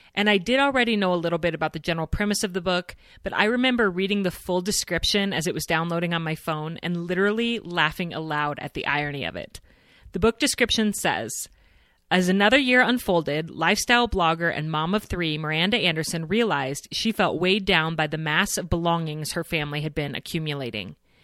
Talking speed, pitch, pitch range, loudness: 195 wpm, 170 Hz, 155-205 Hz, -23 LUFS